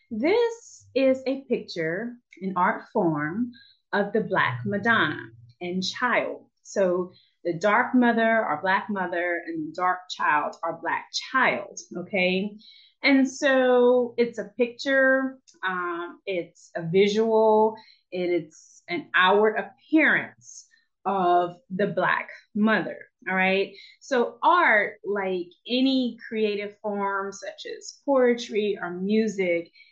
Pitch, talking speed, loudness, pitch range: 210 Hz, 120 wpm, -24 LUFS, 185-255 Hz